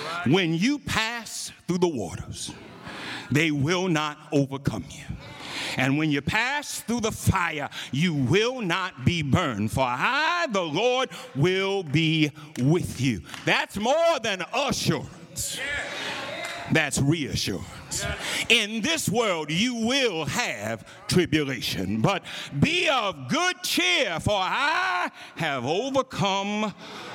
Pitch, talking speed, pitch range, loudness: 180 Hz, 115 wpm, 145-235 Hz, -25 LUFS